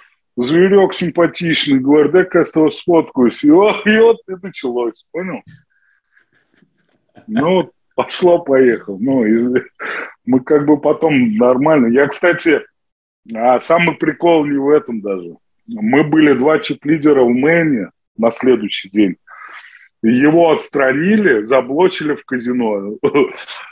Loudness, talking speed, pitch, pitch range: -14 LUFS, 120 wpm, 150 Hz, 125-175 Hz